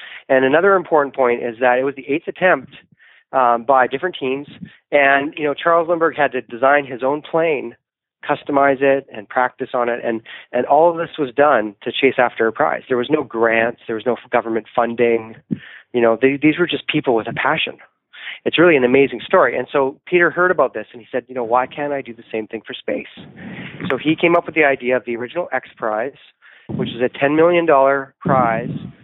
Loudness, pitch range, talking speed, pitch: -17 LUFS, 120-150 Hz, 220 wpm, 135 Hz